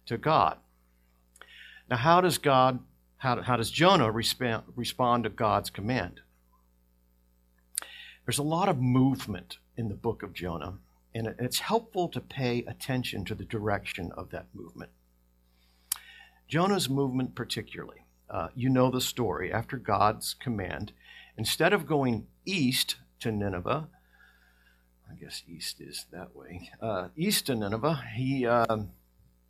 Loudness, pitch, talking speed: -29 LUFS, 110 Hz, 130 wpm